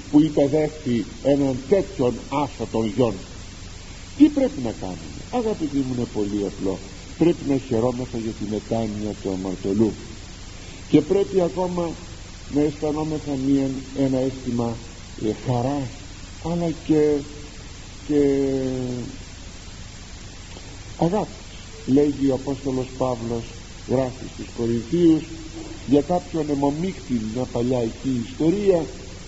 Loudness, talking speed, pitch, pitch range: -23 LUFS, 105 wpm, 125 Hz, 100-145 Hz